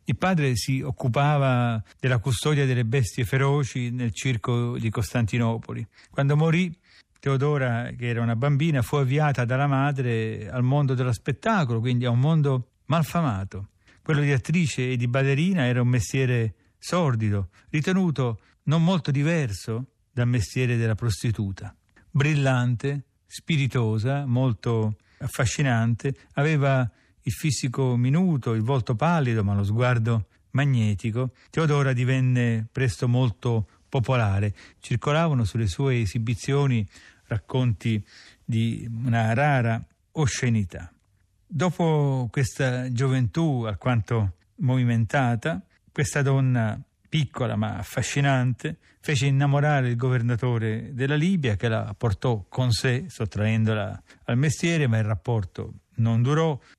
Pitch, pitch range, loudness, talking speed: 125 Hz, 115-140 Hz, -24 LUFS, 115 wpm